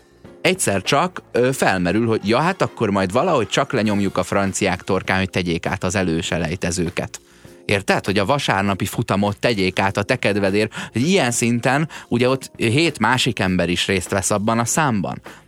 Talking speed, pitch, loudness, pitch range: 170 wpm, 100 Hz, -19 LUFS, 95-120 Hz